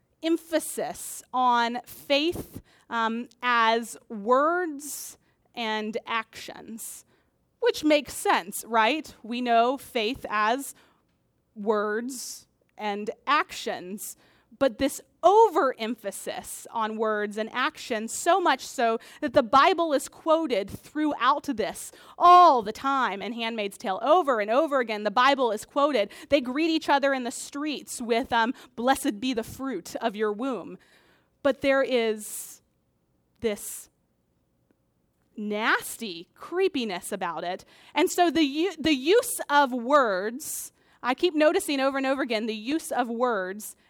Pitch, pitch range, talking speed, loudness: 260 Hz, 225-300 Hz, 125 wpm, -25 LUFS